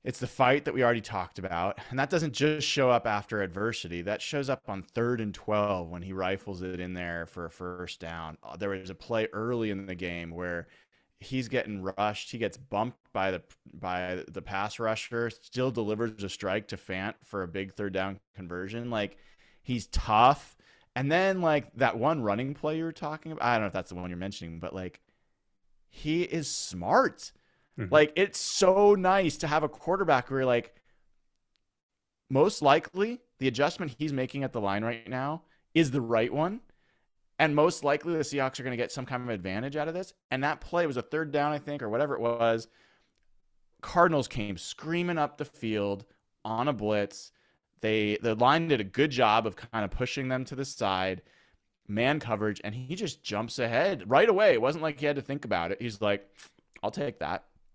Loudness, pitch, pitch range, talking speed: -29 LUFS, 115 Hz, 100-145 Hz, 205 wpm